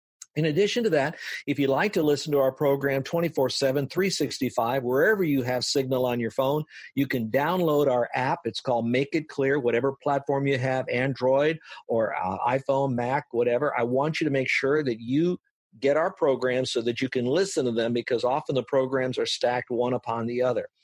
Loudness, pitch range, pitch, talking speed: -25 LUFS, 125-145 Hz, 135 Hz, 200 wpm